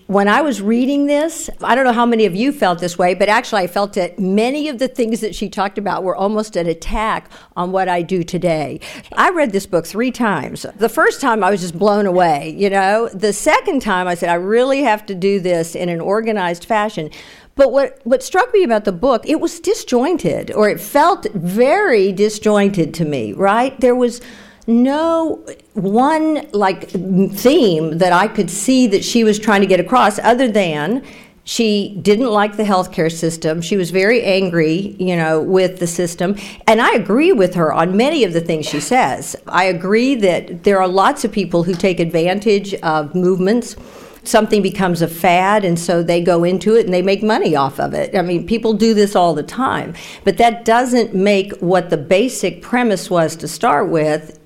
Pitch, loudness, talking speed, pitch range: 200 Hz, -15 LUFS, 200 wpm, 180-230 Hz